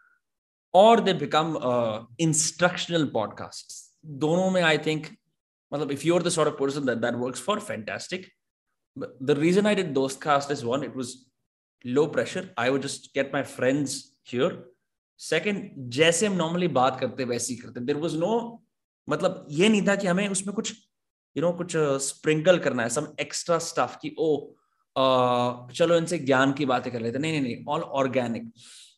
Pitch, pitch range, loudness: 150 Hz, 130-180 Hz, -25 LUFS